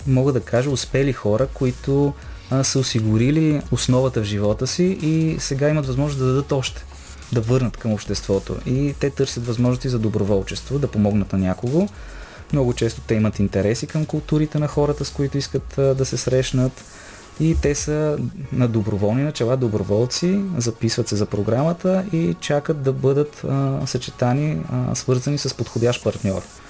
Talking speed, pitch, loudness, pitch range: 160 wpm, 130 Hz, -21 LUFS, 115-145 Hz